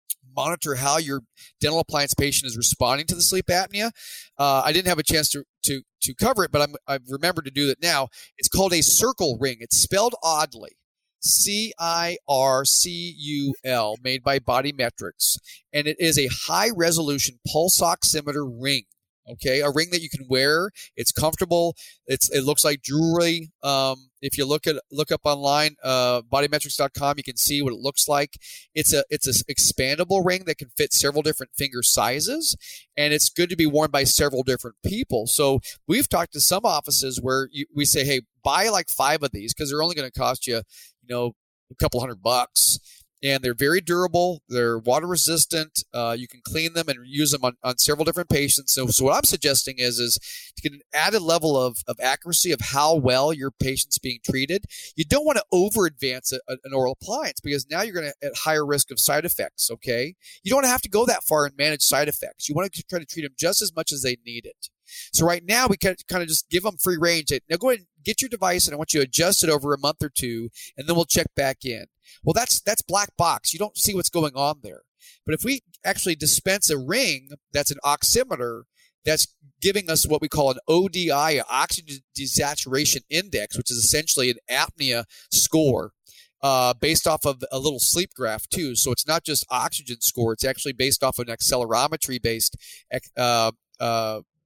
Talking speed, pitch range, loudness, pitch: 210 wpm, 130-165 Hz, -22 LUFS, 145 Hz